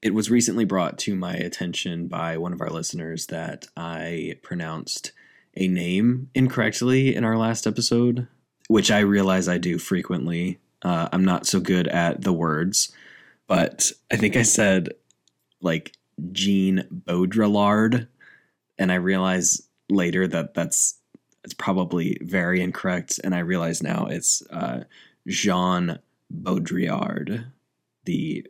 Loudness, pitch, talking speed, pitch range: -23 LUFS, 95 Hz, 135 wpm, 85-110 Hz